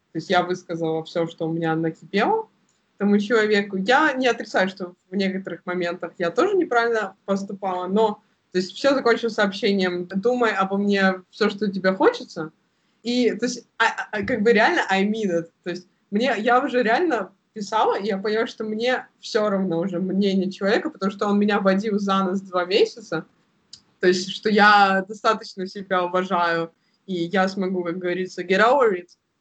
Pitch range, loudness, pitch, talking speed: 180-220 Hz, -22 LUFS, 195 Hz, 180 wpm